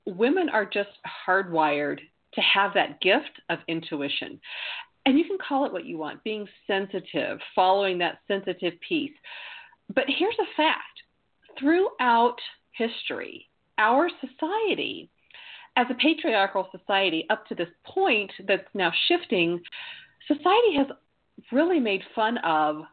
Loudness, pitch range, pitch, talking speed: -25 LUFS, 190-315 Hz, 230 Hz, 130 wpm